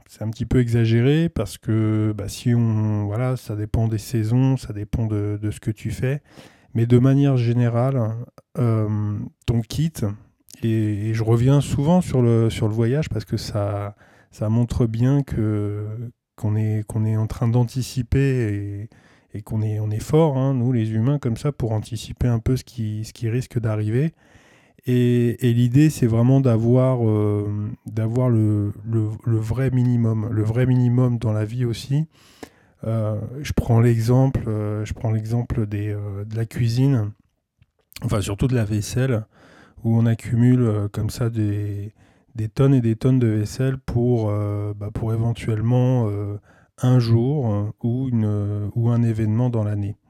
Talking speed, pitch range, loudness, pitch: 165 wpm, 105-125 Hz, -21 LUFS, 115 Hz